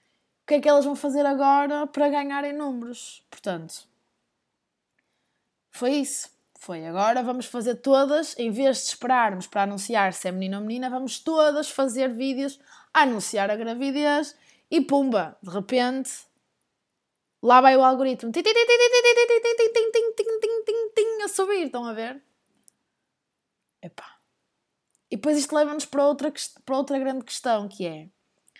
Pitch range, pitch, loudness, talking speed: 235-295 Hz, 270 Hz, -23 LUFS, 150 wpm